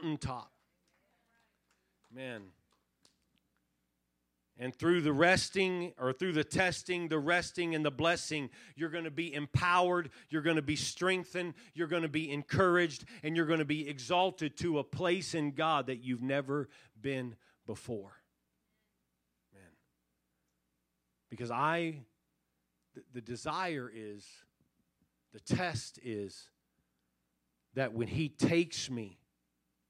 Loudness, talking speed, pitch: -34 LUFS, 120 wpm, 135 Hz